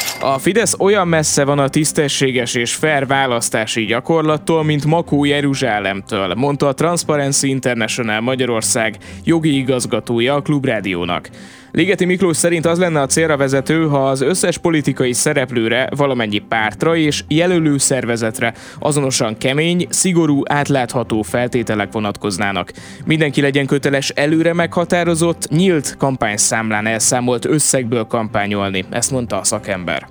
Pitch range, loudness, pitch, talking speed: 115-155 Hz, -16 LUFS, 135 Hz, 120 wpm